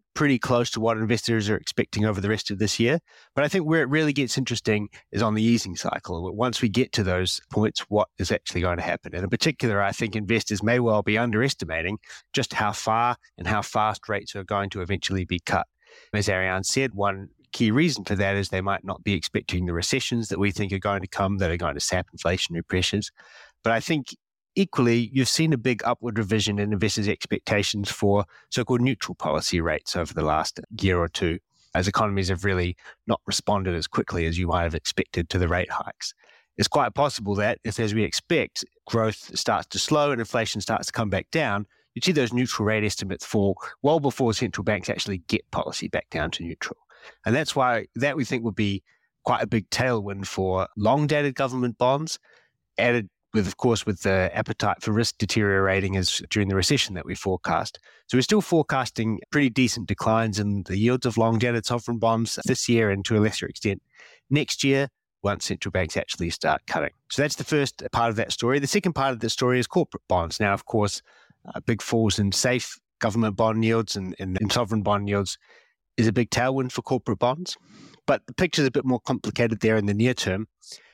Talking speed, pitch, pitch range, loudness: 210 wpm, 110 Hz, 100-125 Hz, -25 LUFS